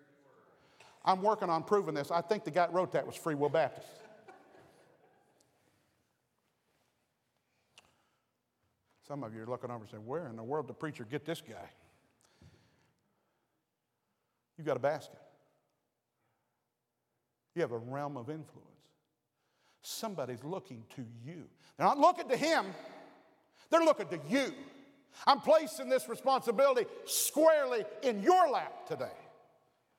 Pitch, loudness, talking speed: 165 Hz, -32 LUFS, 130 wpm